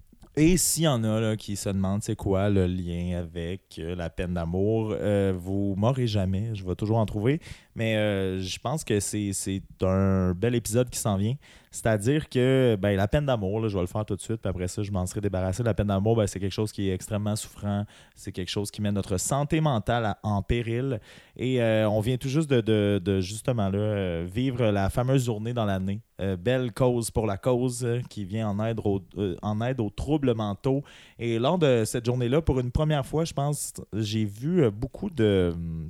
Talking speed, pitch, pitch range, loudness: 215 wpm, 105 Hz, 95-125 Hz, -27 LUFS